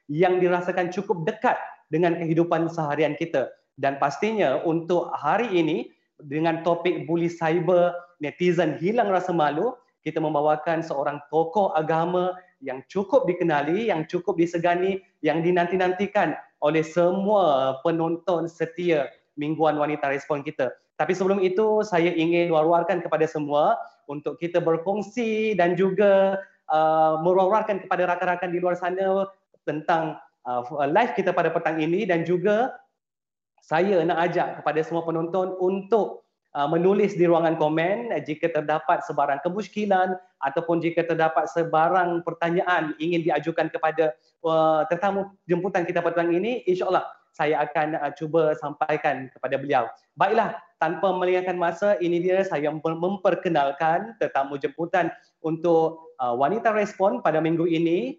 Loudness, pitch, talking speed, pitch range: -24 LUFS, 170 Hz, 130 wpm, 155-185 Hz